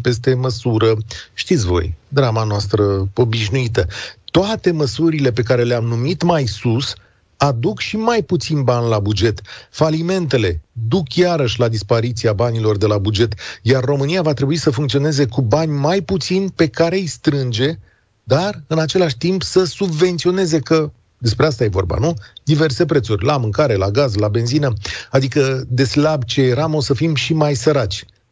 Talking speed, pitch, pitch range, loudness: 160 wpm, 135 Hz, 115-155 Hz, -17 LUFS